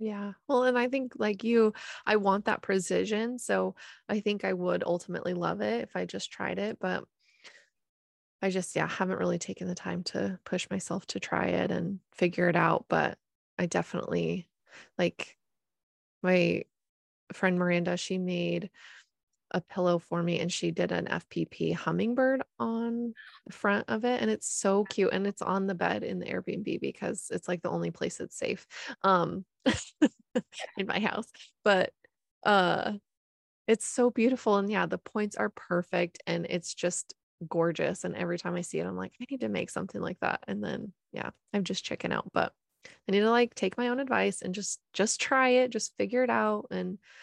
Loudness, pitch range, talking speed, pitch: -30 LUFS, 175-220 Hz, 185 wpm, 195 Hz